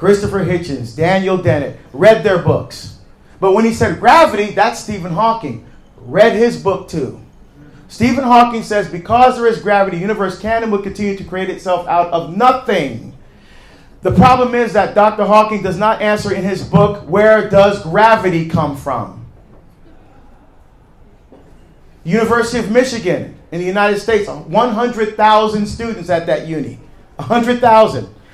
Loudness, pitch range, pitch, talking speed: -13 LUFS, 175-220 Hz, 205 Hz, 140 wpm